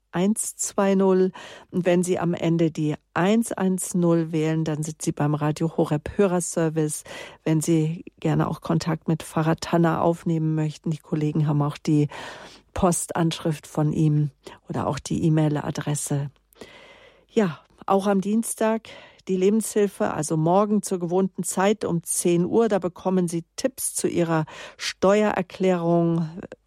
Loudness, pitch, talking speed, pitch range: -24 LUFS, 170 Hz, 135 wpm, 155-190 Hz